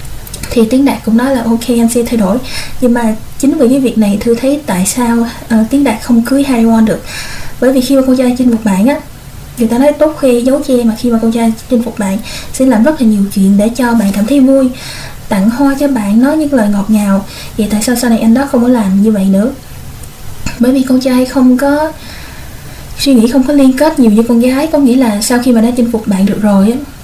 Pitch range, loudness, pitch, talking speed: 225-265 Hz, -10 LUFS, 240 Hz, 260 wpm